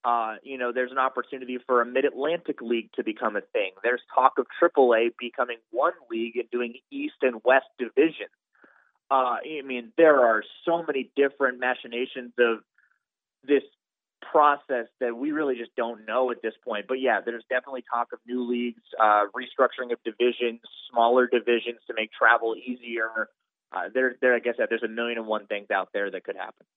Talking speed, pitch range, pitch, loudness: 190 wpm, 120-135 Hz, 125 Hz, -26 LUFS